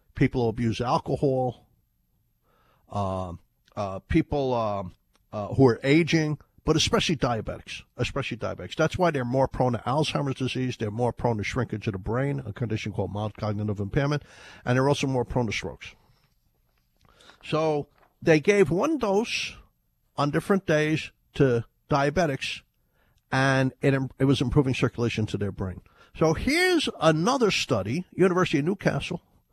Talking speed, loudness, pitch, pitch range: 145 wpm, -26 LUFS, 130 Hz, 105-155 Hz